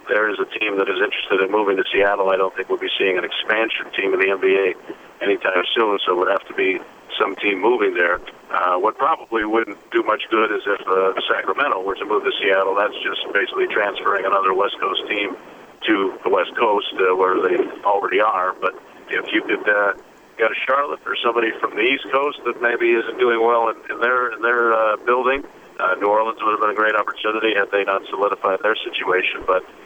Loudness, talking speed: -19 LUFS, 220 wpm